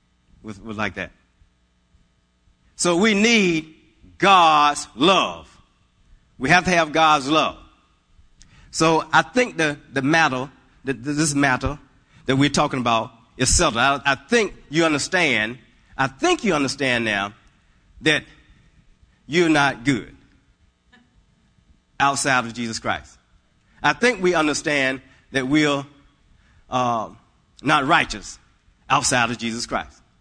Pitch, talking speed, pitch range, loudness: 140 Hz, 120 wpm, 115-155 Hz, -20 LUFS